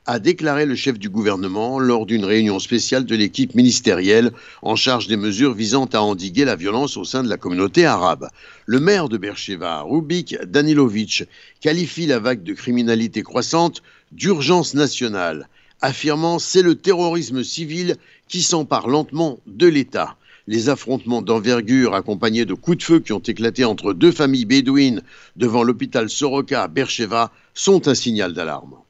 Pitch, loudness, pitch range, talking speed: 130 Hz, -18 LUFS, 115-160 Hz, 160 wpm